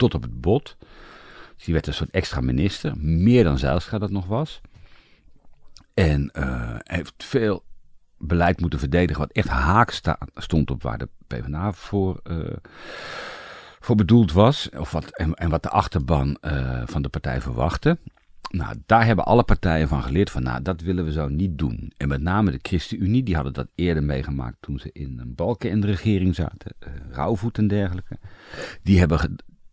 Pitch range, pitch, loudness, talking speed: 70-100 Hz, 85 Hz, -23 LUFS, 180 wpm